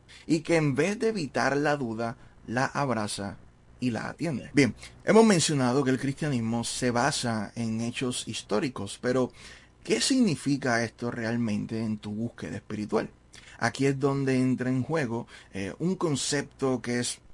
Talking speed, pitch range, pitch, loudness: 150 wpm, 115-140 Hz, 125 Hz, -28 LUFS